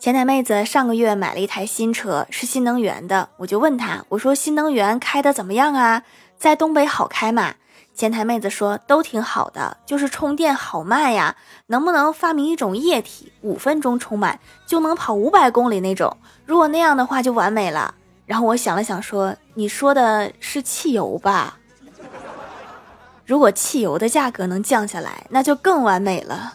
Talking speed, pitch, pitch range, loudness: 270 characters per minute, 245 Hz, 210-285 Hz, -19 LUFS